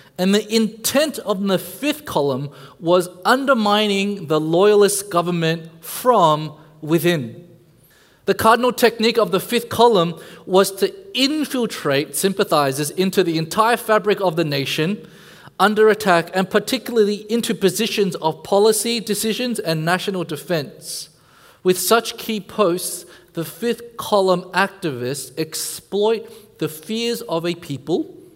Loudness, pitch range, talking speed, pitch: -19 LUFS, 165-220 Hz, 125 wpm, 195 Hz